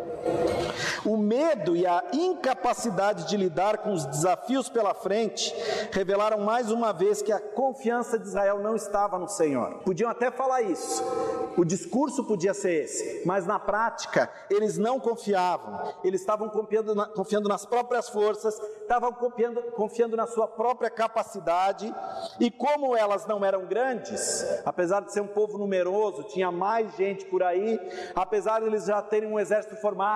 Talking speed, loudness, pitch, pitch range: 160 wpm, -27 LUFS, 215 Hz, 200-235 Hz